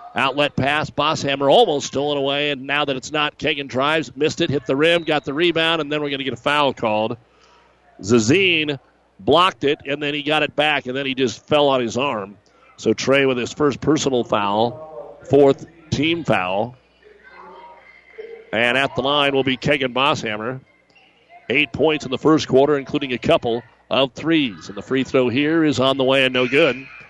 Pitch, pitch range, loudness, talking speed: 140 Hz, 130-150 Hz, -19 LUFS, 195 wpm